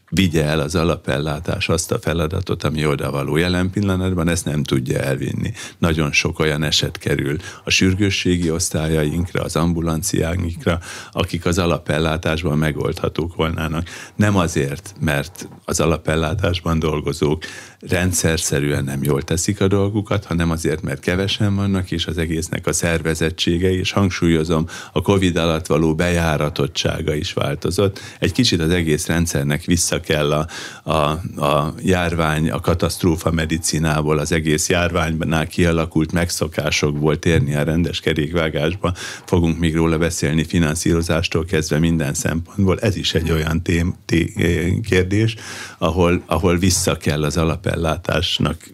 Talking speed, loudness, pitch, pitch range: 135 wpm, -19 LUFS, 85 Hz, 80-90 Hz